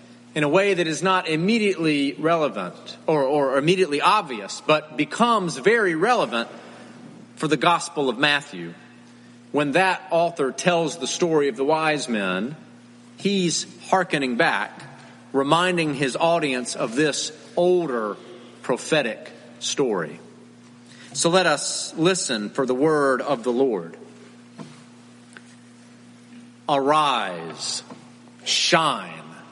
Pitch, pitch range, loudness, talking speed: 145 Hz, 120-170 Hz, -22 LUFS, 110 wpm